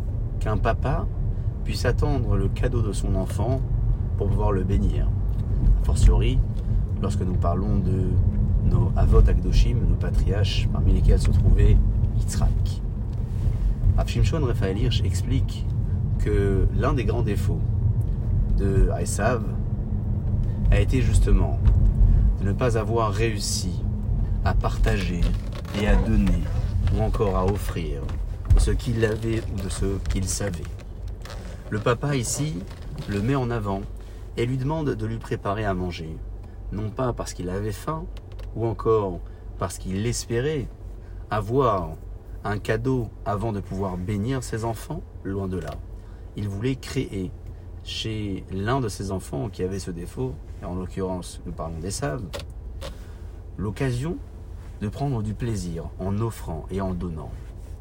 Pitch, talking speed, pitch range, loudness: 100 Hz, 140 wpm, 95-110 Hz, -25 LUFS